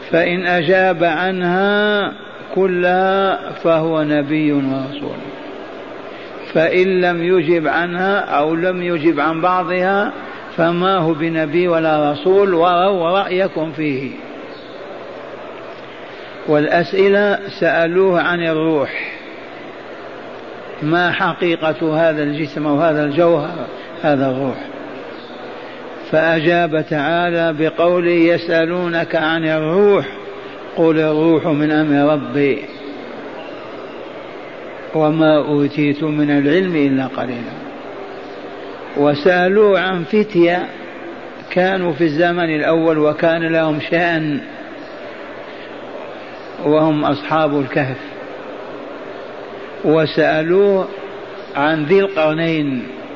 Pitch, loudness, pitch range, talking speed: 165 Hz, -16 LUFS, 155-180 Hz, 80 wpm